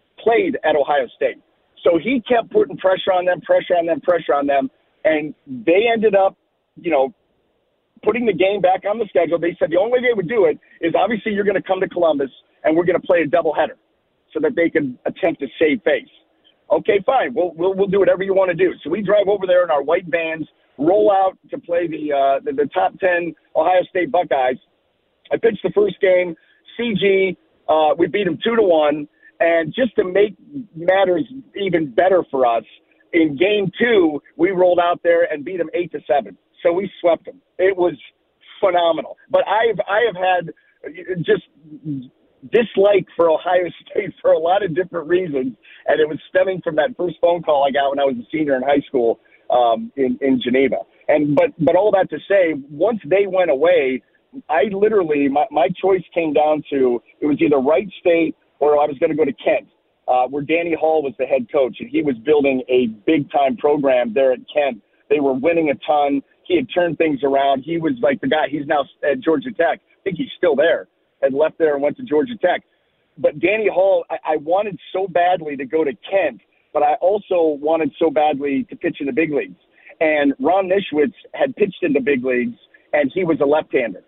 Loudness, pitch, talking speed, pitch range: -18 LUFS, 175 Hz, 215 wpm, 150-205 Hz